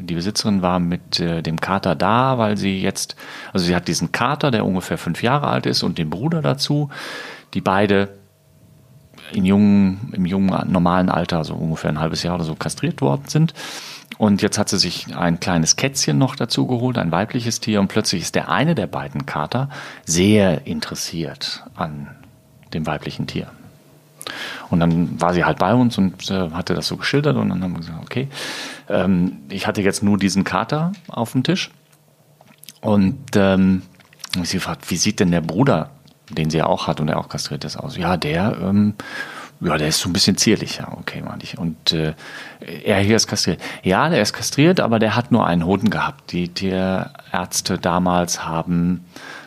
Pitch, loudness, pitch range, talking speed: 95 Hz, -19 LUFS, 85-110 Hz, 190 wpm